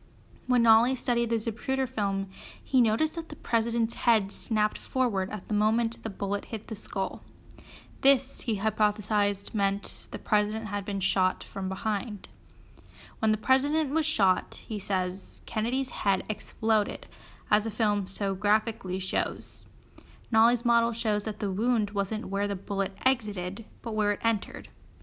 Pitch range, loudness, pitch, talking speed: 205-235 Hz, -28 LUFS, 220 Hz, 155 wpm